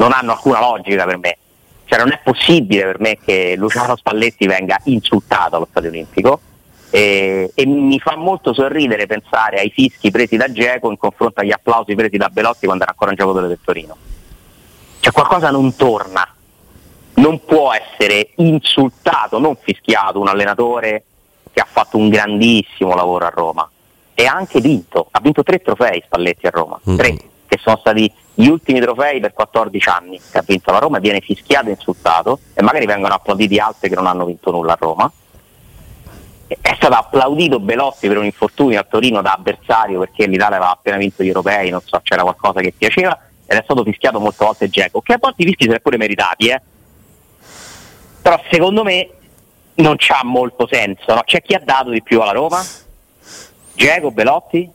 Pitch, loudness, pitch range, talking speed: 110 Hz, -14 LUFS, 95-130 Hz, 180 wpm